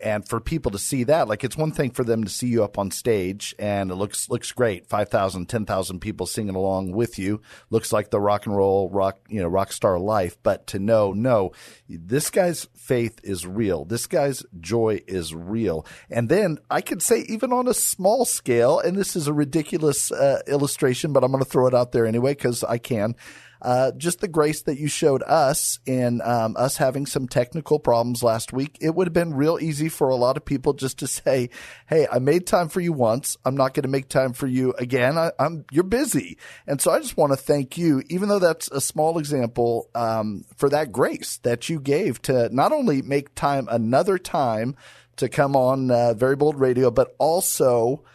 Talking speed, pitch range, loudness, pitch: 215 wpm, 115-150 Hz, -22 LUFS, 130 Hz